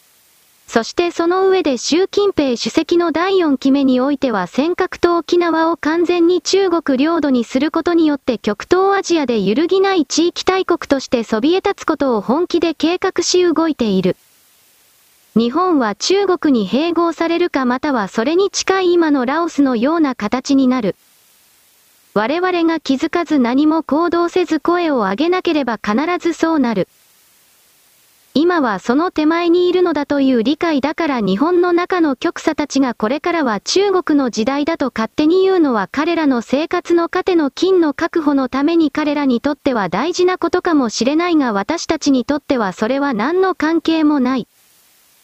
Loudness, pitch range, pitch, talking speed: -16 LUFS, 265-345 Hz, 315 Hz, 320 characters per minute